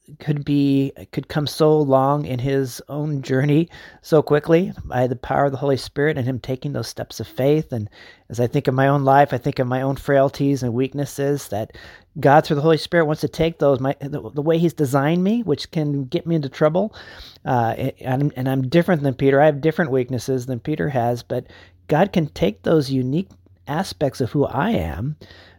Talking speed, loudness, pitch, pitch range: 210 wpm, -20 LUFS, 140 Hz, 130-150 Hz